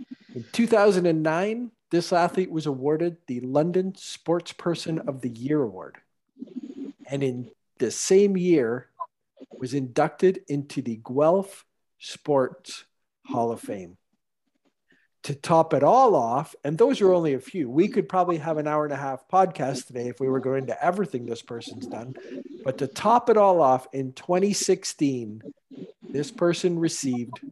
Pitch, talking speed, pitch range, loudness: 160 Hz, 155 wpm, 135-190 Hz, -24 LUFS